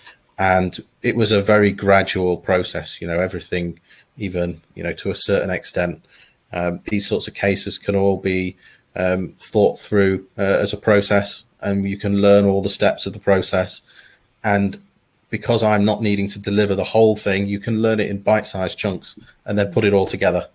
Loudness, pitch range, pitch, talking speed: -19 LUFS, 95-105 Hz, 100 Hz, 195 wpm